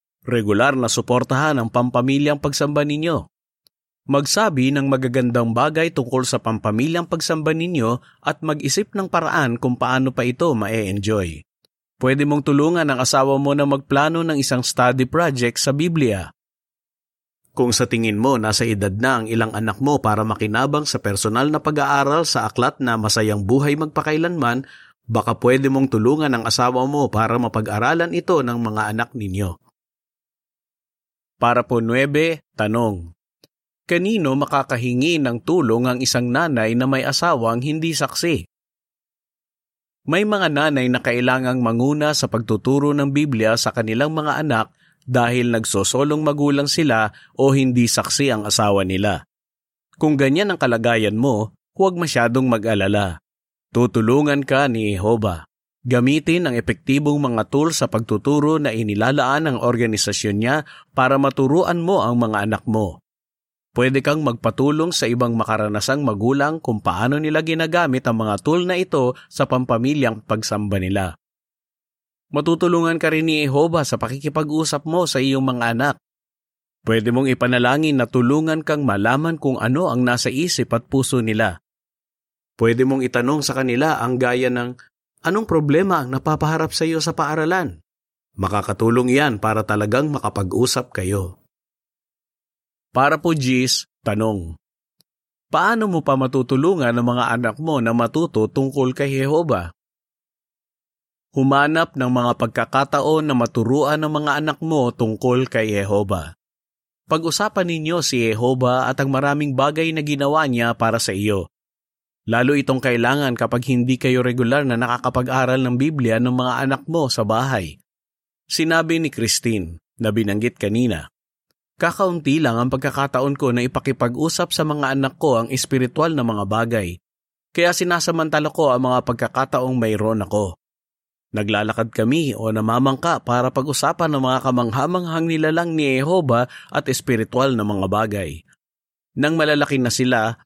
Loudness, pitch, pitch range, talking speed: -19 LUFS, 130 Hz, 115-145 Hz, 140 wpm